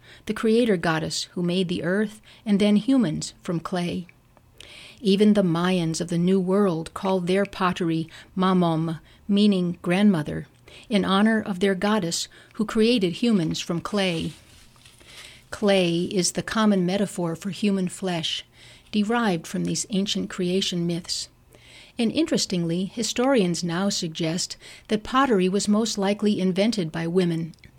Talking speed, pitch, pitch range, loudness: 135 wpm, 185 Hz, 170-205 Hz, -24 LUFS